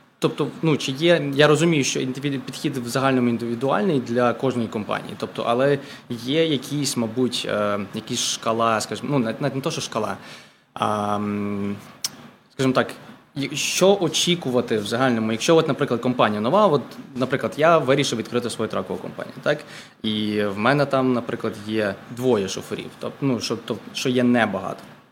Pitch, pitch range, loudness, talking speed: 125 Hz, 115-140 Hz, -22 LUFS, 150 wpm